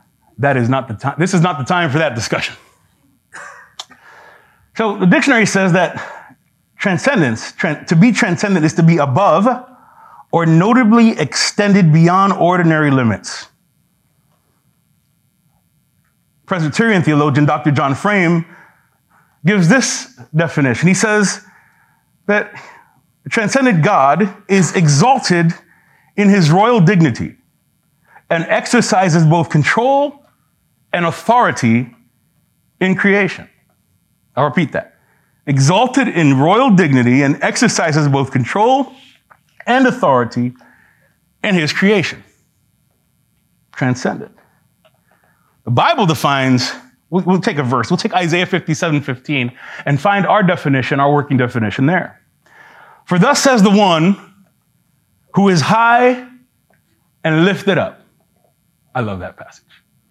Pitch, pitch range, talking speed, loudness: 175 Hz, 150-205 Hz, 115 wpm, -14 LUFS